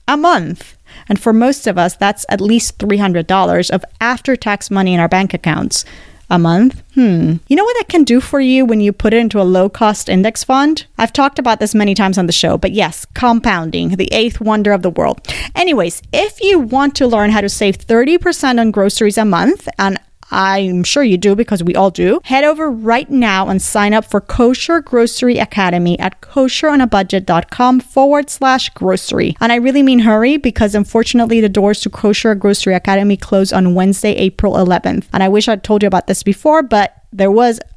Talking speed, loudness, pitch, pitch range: 200 wpm, -12 LUFS, 215 Hz, 195-250 Hz